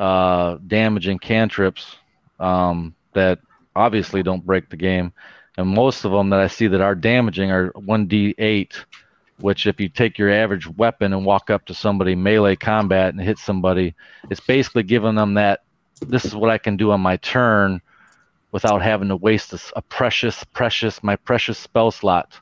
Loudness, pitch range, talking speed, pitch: -19 LUFS, 95-110 Hz, 175 wpm, 100 Hz